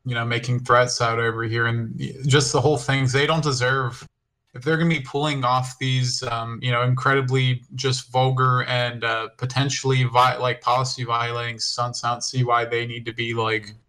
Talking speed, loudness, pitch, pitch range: 200 wpm, -22 LUFS, 125 Hz, 120-130 Hz